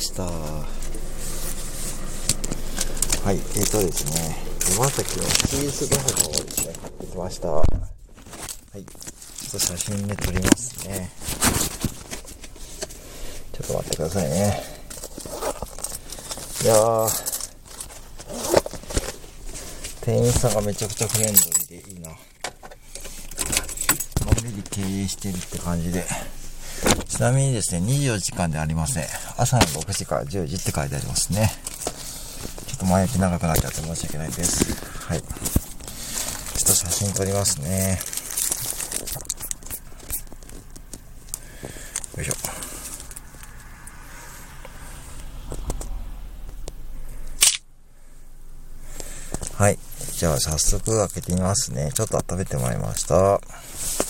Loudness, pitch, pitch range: -24 LUFS, 95 Hz, 85-105 Hz